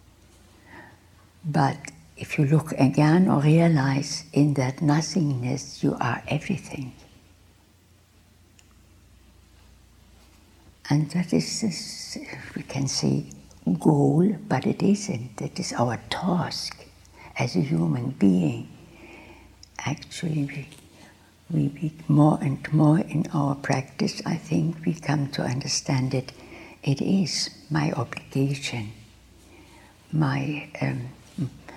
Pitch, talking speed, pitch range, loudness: 140 Hz, 105 wpm, 100-155 Hz, -25 LUFS